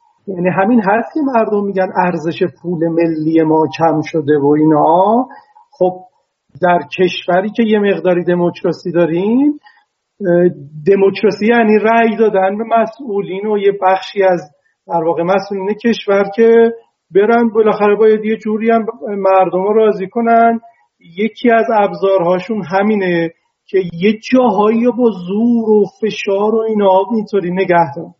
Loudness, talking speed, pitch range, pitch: -13 LUFS, 130 wpm, 180-220 Hz, 200 Hz